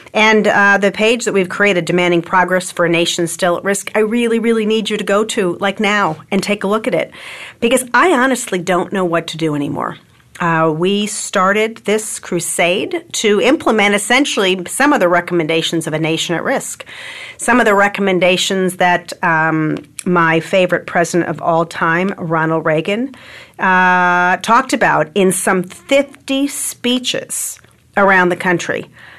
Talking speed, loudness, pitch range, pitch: 165 wpm, -14 LUFS, 170-215 Hz, 185 Hz